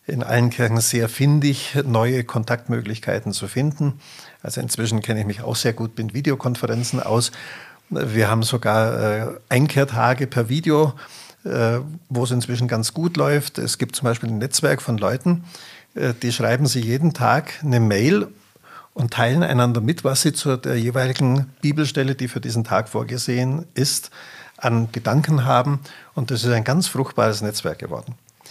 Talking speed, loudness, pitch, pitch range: 155 wpm, -21 LUFS, 125 Hz, 115-140 Hz